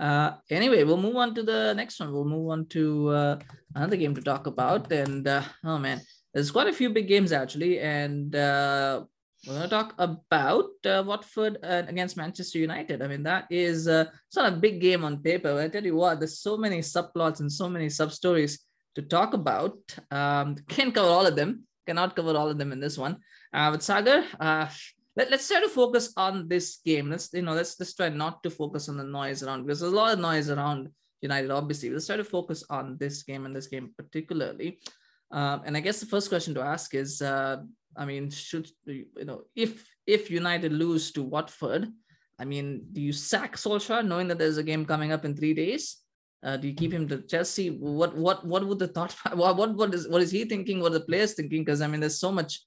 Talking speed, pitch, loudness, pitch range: 225 wpm, 160 Hz, -27 LUFS, 145-185 Hz